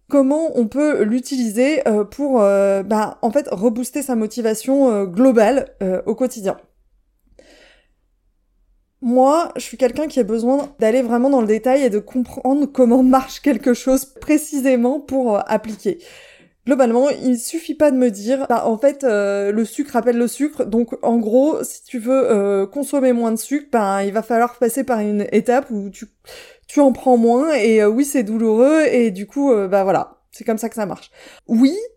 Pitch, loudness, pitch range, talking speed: 245 Hz, -17 LUFS, 220-270 Hz, 185 wpm